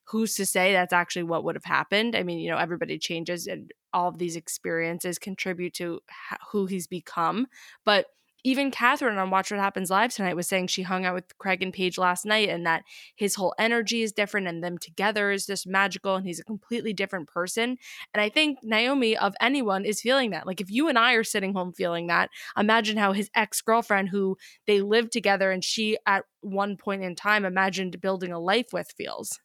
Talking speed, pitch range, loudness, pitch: 215 wpm, 180-220 Hz, -26 LUFS, 195 Hz